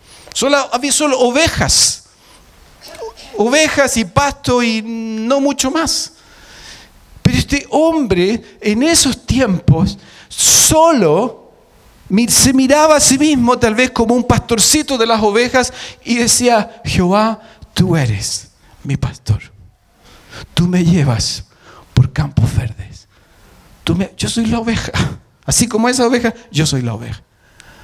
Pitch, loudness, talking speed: 225 Hz, -13 LUFS, 125 wpm